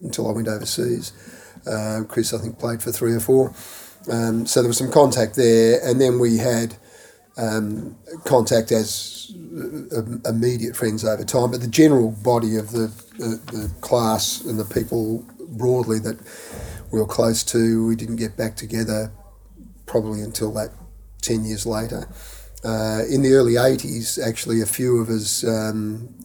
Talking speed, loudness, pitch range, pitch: 165 wpm, -21 LUFS, 110-120 Hz, 115 Hz